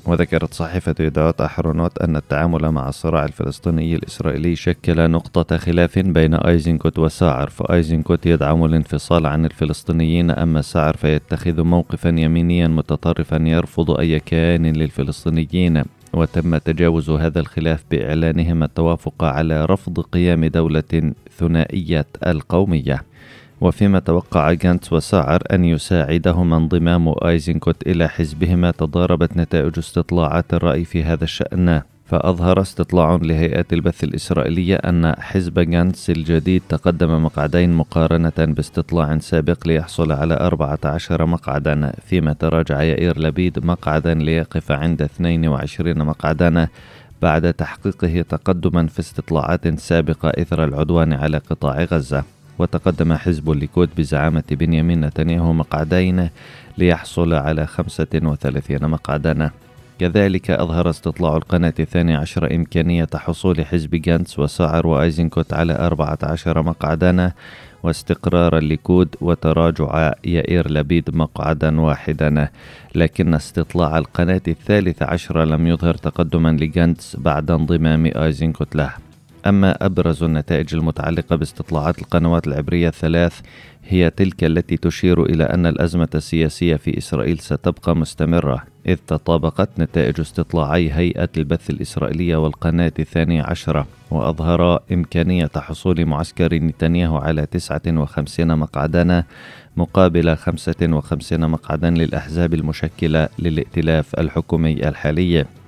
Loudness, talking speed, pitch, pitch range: -18 LUFS, 110 wpm, 80 Hz, 80-85 Hz